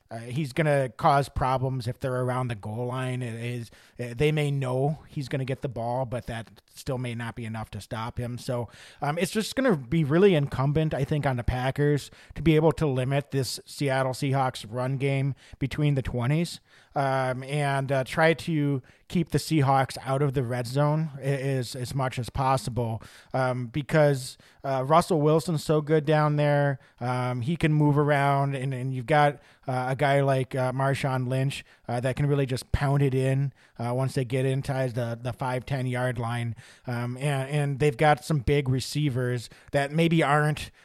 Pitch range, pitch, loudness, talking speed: 125-145 Hz, 135 Hz, -26 LUFS, 195 wpm